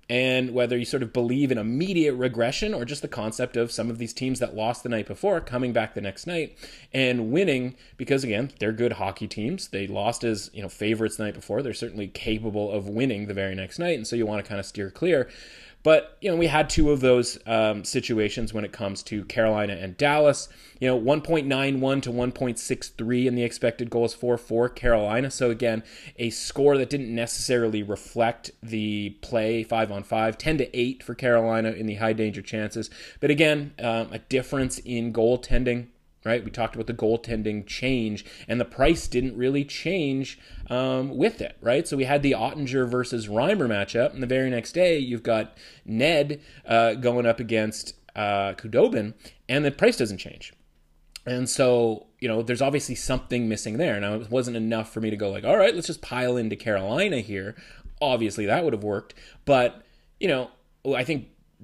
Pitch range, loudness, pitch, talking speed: 110-130 Hz, -25 LUFS, 120 Hz, 200 wpm